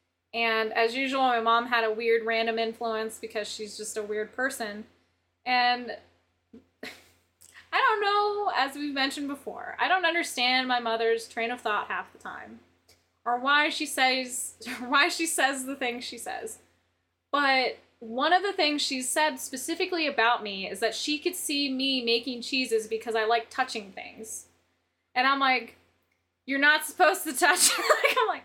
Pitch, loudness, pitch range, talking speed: 255 Hz, -26 LUFS, 230-290 Hz, 170 wpm